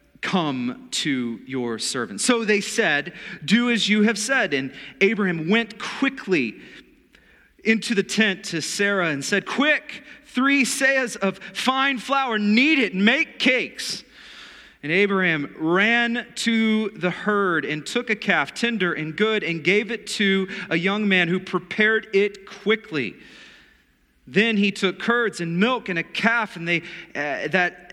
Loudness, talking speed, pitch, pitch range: -21 LUFS, 155 wpm, 205 Hz, 180-235 Hz